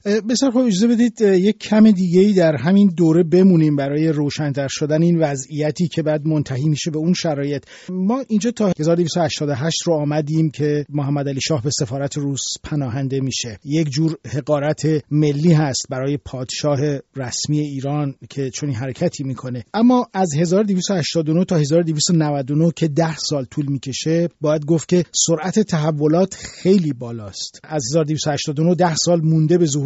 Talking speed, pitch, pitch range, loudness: 150 wpm, 155 Hz, 145-175 Hz, -18 LUFS